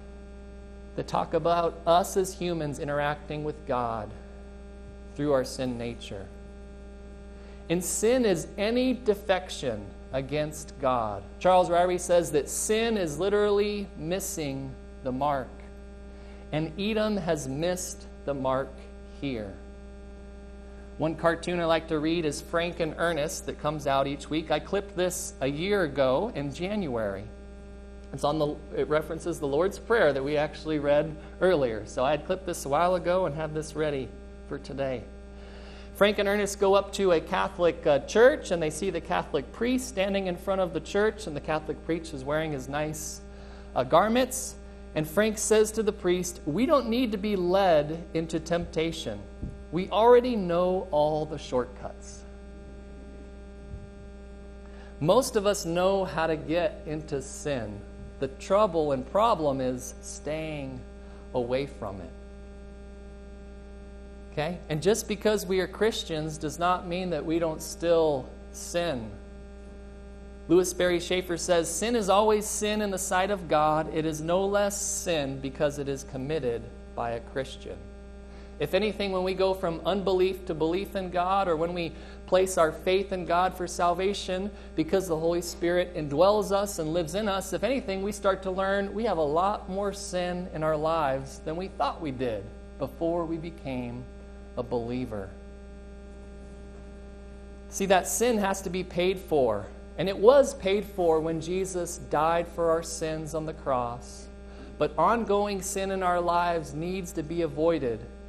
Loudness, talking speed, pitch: -28 LUFS, 160 wpm, 160 Hz